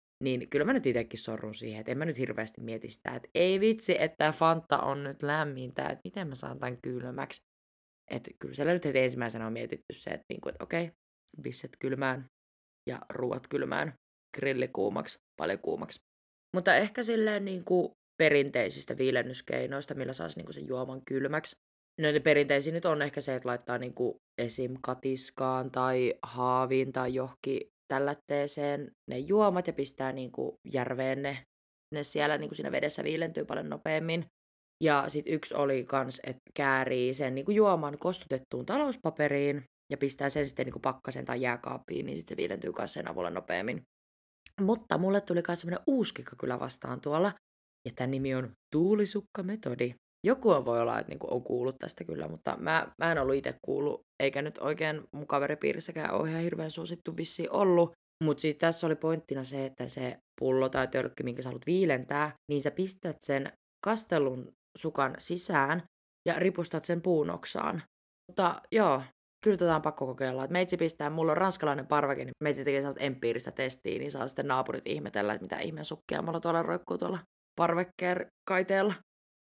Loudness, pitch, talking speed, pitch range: -32 LUFS, 145 Hz, 175 wpm, 130-170 Hz